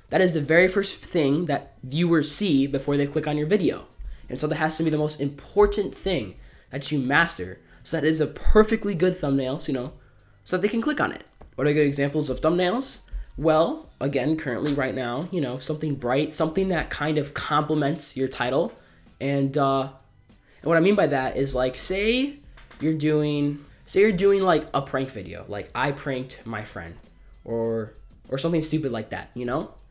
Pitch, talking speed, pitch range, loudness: 145 Hz, 200 wpm, 130-160 Hz, -24 LUFS